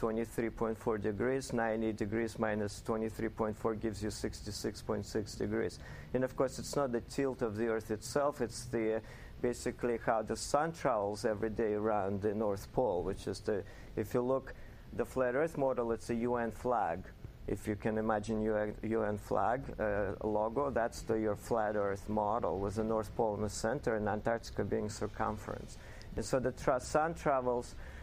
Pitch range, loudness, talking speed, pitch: 105-120 Hz, -36 LUFS, 170 wpm, 110 Hz